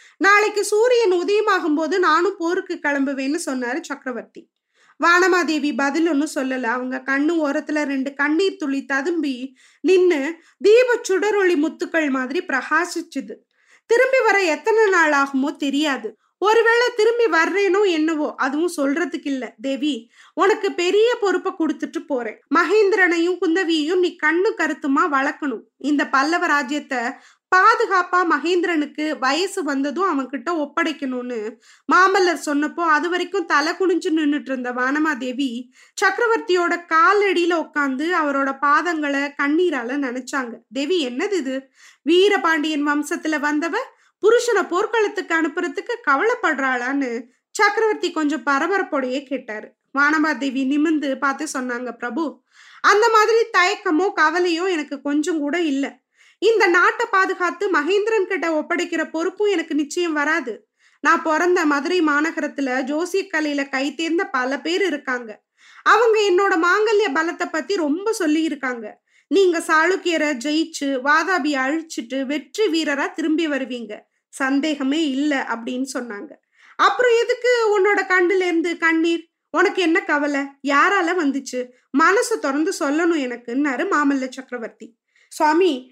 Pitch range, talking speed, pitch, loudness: 280-370 Hz, 110 wpm, 320 Hz, -19 LUFS